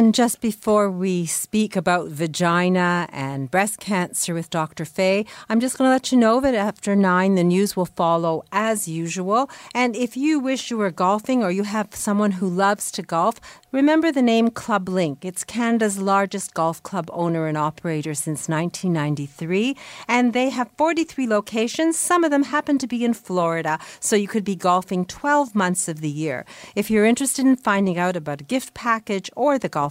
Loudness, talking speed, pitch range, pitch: -21 LUFS, 190 wpm, 175-240 Hz, 200 Hz